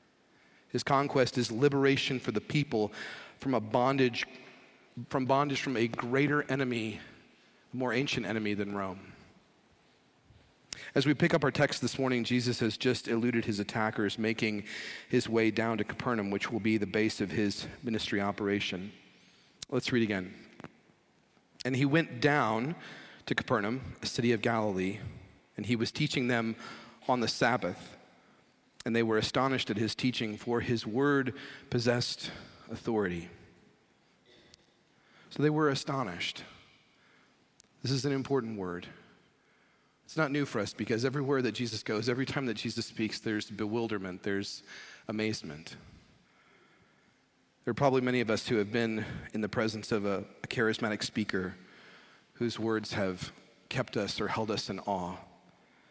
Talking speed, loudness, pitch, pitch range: 150 wpm, -32 LUFS, 115 Hz, 110-130 Hz